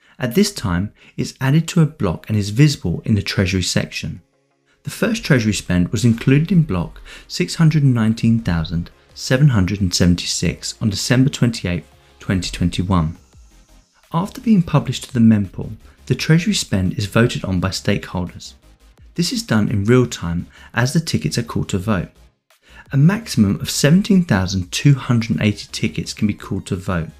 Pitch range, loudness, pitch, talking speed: 90-145 Hz, -18 LUFS, 110 Hz, 145 wpm